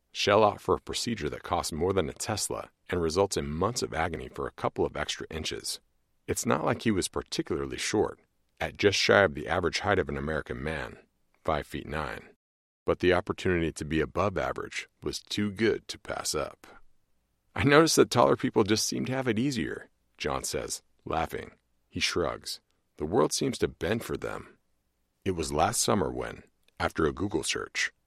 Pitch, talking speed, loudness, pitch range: 90 Hz, 190 wpm, -29 LUFS, 70-110 Hz